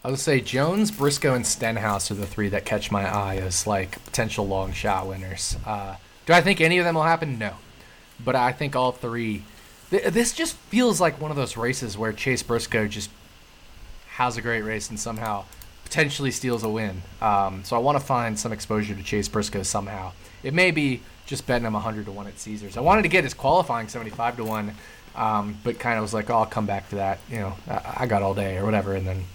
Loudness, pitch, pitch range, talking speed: -24 LUFS, 110 Hz, 100-125 Hz, 230 wpm